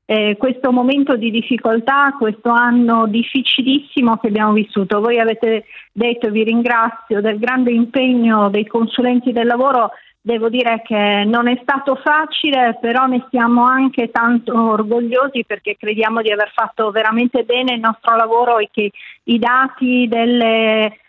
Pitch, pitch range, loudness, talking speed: 235 Hz, 225-250 Hz, -15 LUFS, 145 wpm